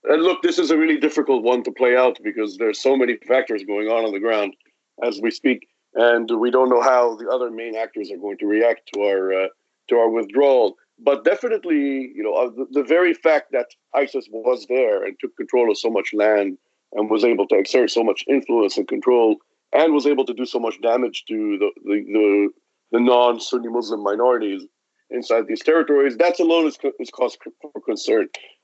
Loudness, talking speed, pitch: -20 LUFS, 210 wpm, 130 Hz